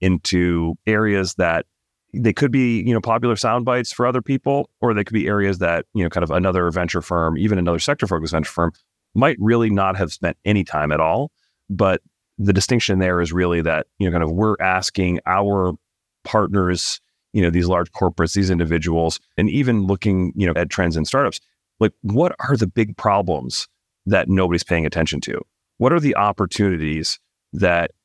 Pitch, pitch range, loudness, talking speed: 95 Hz, 85-110 Hz, -19 LUFS, 190 wpm